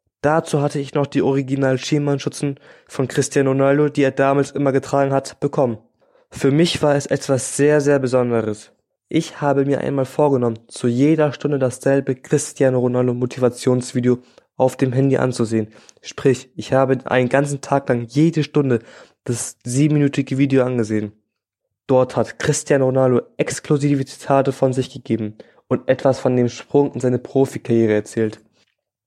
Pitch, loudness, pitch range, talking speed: 135 Hz, -19 LUFS, 125-140 Hz, 145 wpm